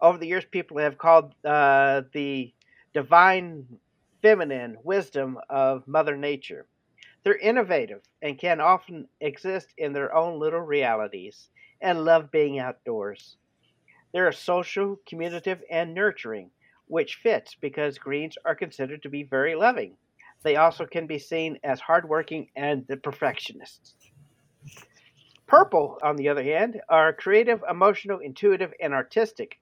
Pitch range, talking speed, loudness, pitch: 140-180 Hz, 135 wpm, -24 LUFS, 155 Hz